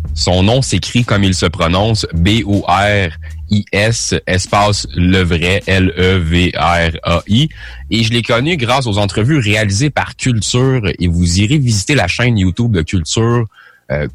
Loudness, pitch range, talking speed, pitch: -13 LUFS, 90-115 Hz, 135 wpm, 100 Hz